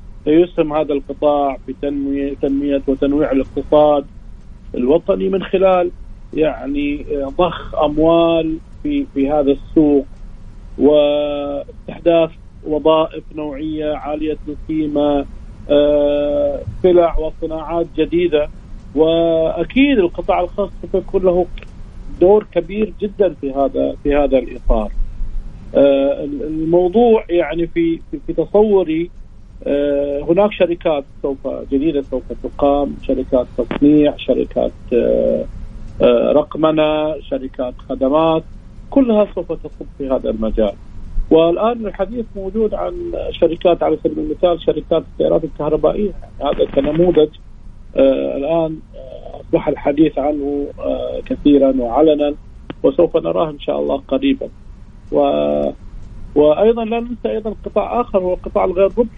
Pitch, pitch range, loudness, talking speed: 150 Hz, 135-175 Hz, -16 LUFS, 100 wpm